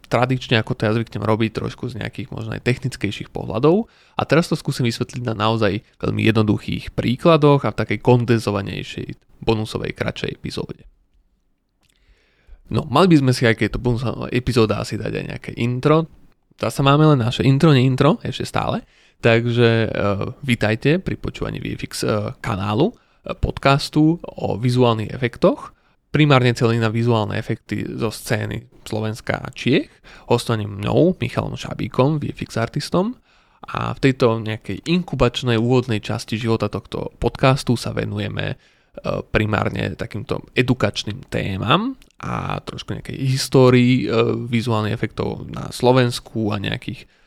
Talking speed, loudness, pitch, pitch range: 140 wpm, -20 LUFS, 120 Hz, 110-135 Hz